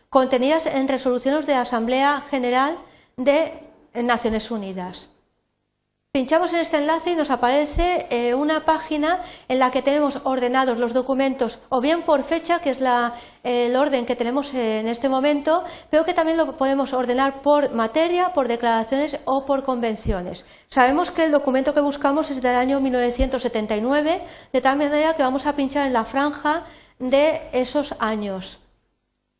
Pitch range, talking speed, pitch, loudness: 250-305 Hz, 155 wpm, 275 Hz, -21 LUFS